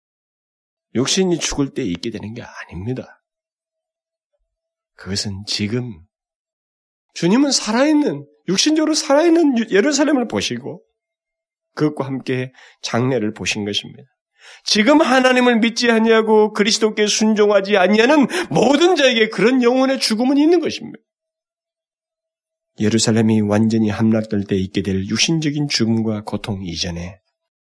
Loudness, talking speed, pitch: -16 LUFS, 275 characters per minute, 220 Hz